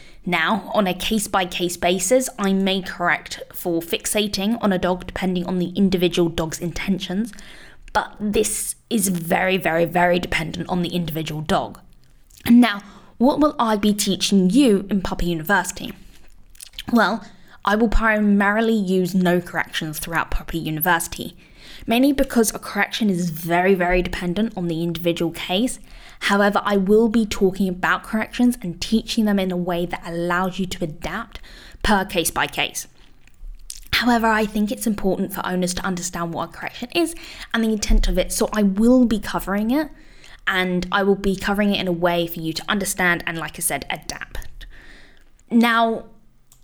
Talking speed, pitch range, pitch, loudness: 165 wpm, 175-220 Hz, 195 Hz, -21 LUFS